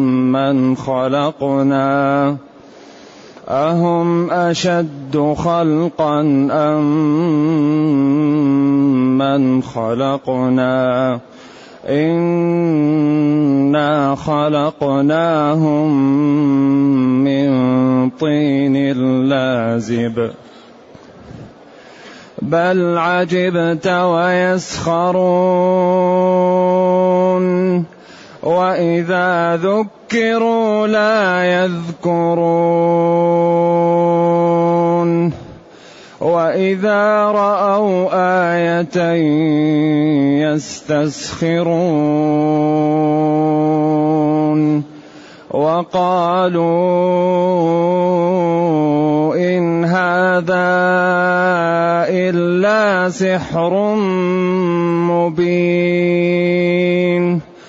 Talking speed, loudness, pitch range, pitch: 30 wpm, -15 LUFS, 150-180 Hz, 170 Hz